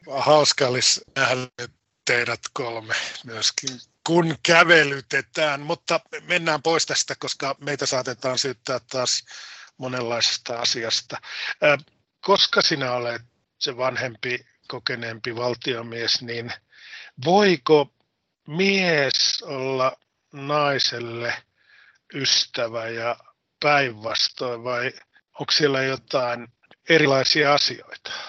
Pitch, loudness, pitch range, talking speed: 135 Hz, -22 LUFS, 120-150 Hz, 85 wpm